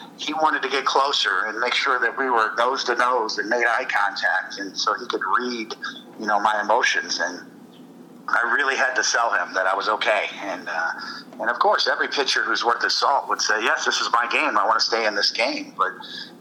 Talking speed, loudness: 235 wpm, -21 LUFS